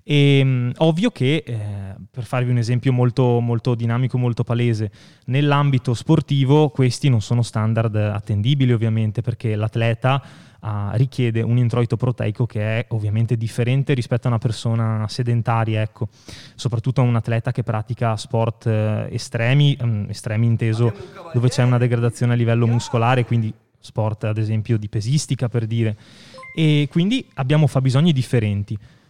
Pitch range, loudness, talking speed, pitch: 115-130 Hz, -20 LUFS, 140 wpm, 120 Hz